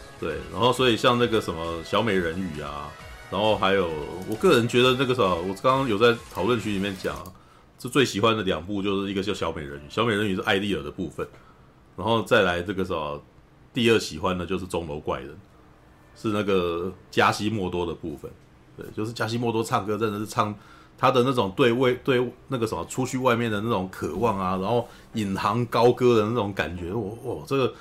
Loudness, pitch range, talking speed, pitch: -25 LUFS, 95-120 Hz, 315 characters per minute, 105 Hz